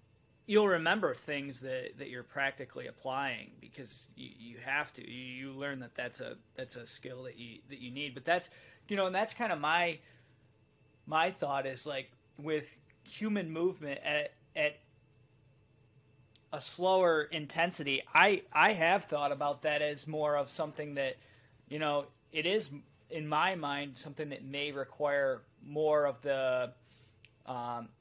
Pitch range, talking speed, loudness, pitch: 125-155 Hz, 160 wpm, -33 LUFS, 140 Hz